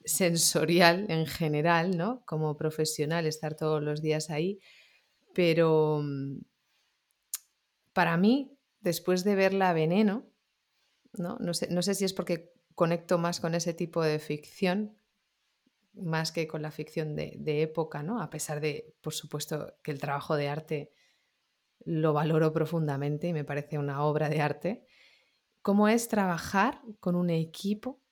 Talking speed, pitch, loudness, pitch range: 145 wpm, 165 Hz, -29 LUFS, 155-185 Hz